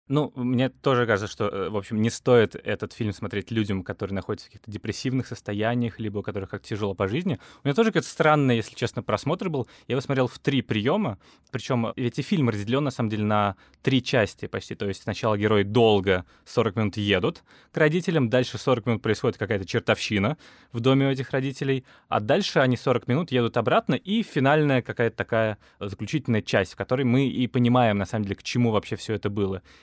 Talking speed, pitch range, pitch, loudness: 205 wpm, 105-135 Hz, 120 Hz, -25 LUFS